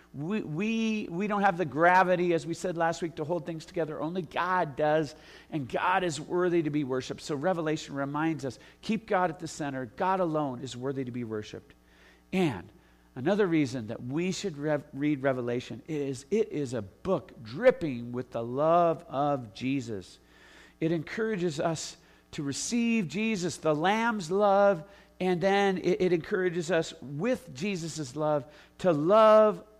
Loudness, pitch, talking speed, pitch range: -29 LUFS, 165 Hz, 165 wpm, 140-185 Hz